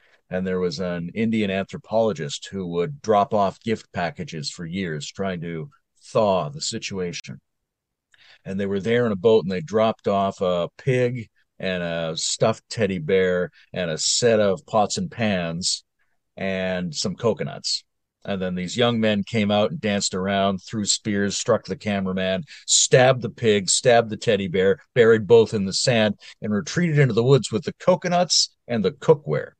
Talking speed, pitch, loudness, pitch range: 170 wpm, 100 Hz, -22 LUFS, 95-120 Hz